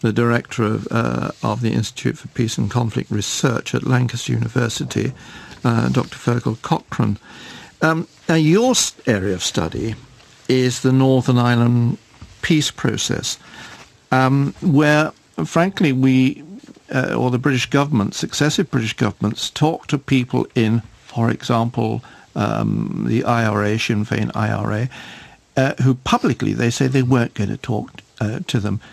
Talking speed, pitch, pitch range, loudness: 145 wpm, 125 Hz, 115-135 Hz, -19 LUFS